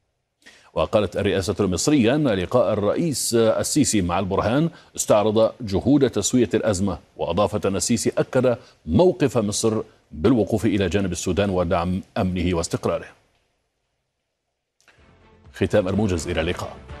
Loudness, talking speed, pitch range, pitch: -21 LUFS, 105 wpm, 95-115 Hz, 100 Hz